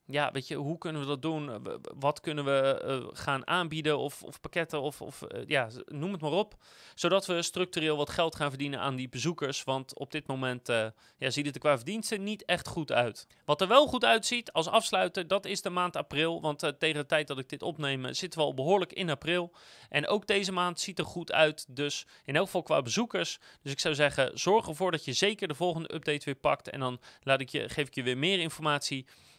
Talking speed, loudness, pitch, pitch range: 235 wpm, -31 LUFS, 155 Hz, 140-180 Hz